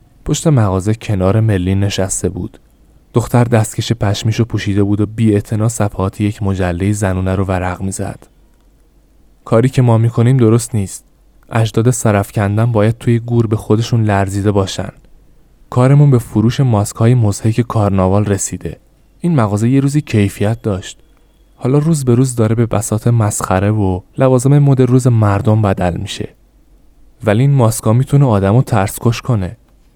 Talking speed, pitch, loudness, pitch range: 150 wpm, 110 Hz, -14 LUFS, 100-120 Hz